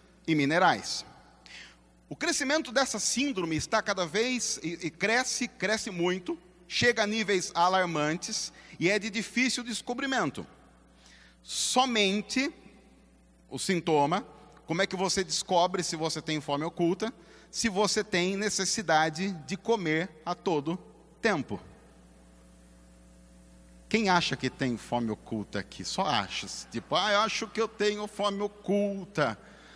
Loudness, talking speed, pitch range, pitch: -29 LUFS, 125 wpm, 155-220 Hz, 185 Hz